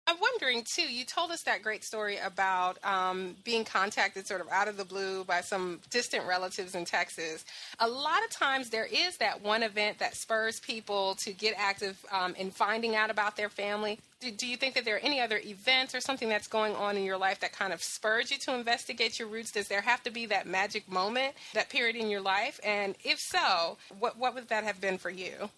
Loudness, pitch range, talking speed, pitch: -31 LUFS, 195-240 Hz, 230 wpm, 210 Hz